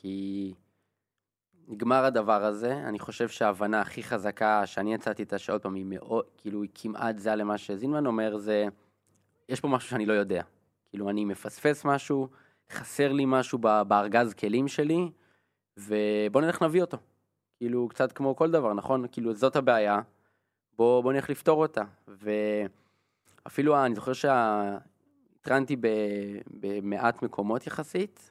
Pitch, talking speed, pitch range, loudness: 110 Hz, 135 wpm, 105-130 Hz, -28 LUFS